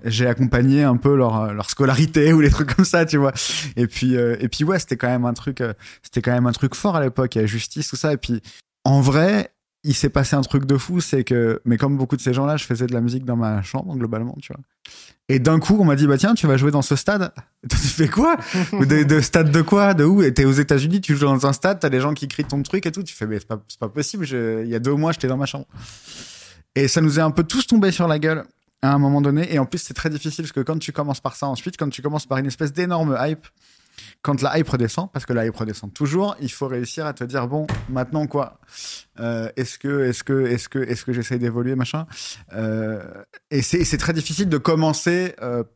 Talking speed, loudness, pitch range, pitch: 270 wpm, -20 LUFS, 125-155 Hz, 140 Hz